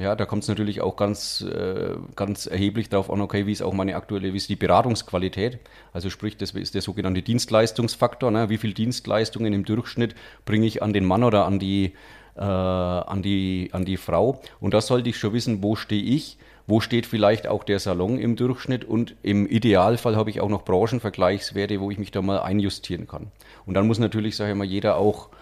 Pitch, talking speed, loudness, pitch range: 105 Hz, 210 wpm, -24 LUFS, 100-110 Hz